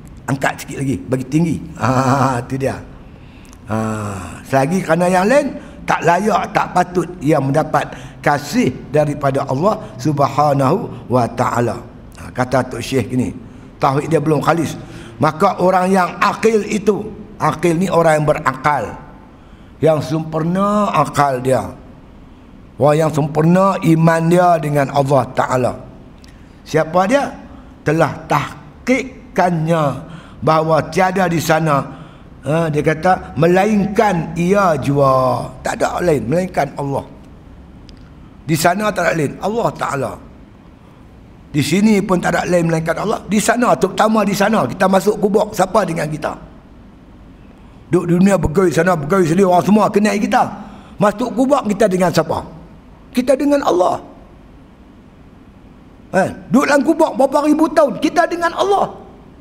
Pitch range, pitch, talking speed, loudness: 135-200 Hz, 160 Hz, 130 wpm, -16 LUFS